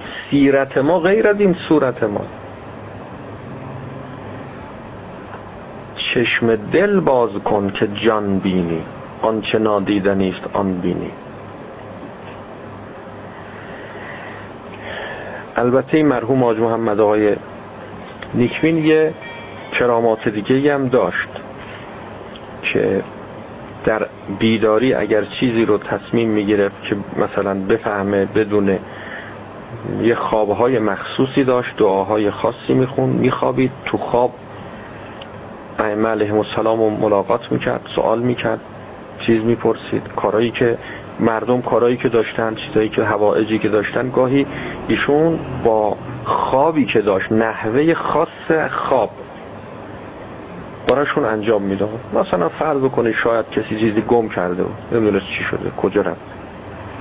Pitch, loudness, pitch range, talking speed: 110 Hz, -17 LUFS, 105-125 Hz, 105 wpm